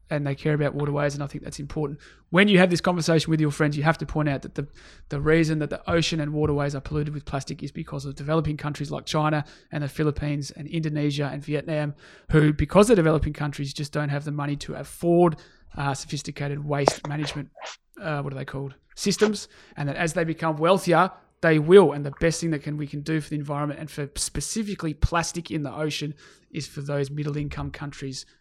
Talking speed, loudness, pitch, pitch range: 220 wpm, -25 LUFS, 150 Hz, 145-160 Hz